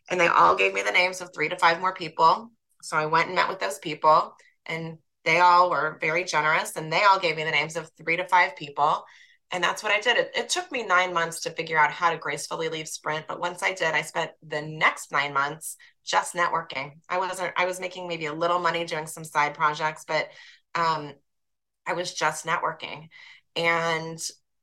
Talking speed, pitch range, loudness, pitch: 220 wpm, 155-175 Hz, -24 LUFS, 165 Hz